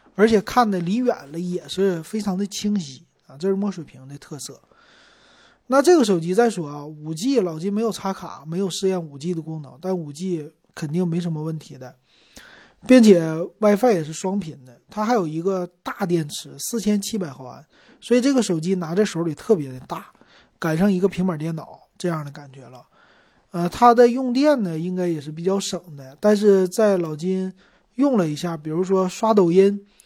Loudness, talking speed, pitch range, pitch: -21 LUFS, 280 characters per minute, 160-210 Hz, 185 Hz